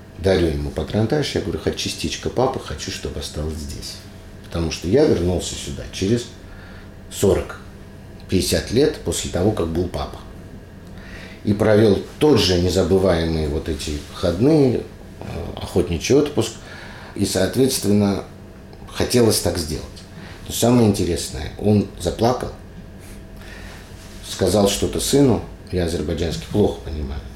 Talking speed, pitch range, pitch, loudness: 115 wpm, 85-105 Hz, 95 Hz, -20 LUFS